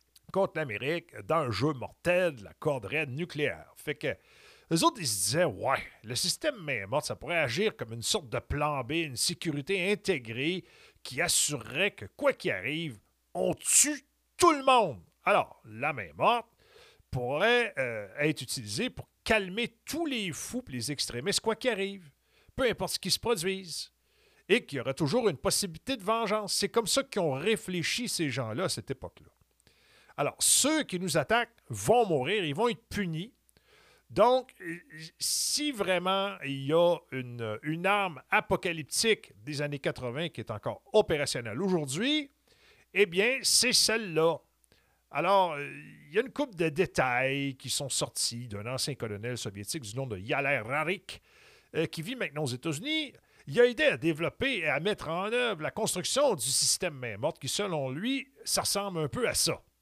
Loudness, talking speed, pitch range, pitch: -29 LUFS, 170 wpm, 140-215 Hz, 170 Hz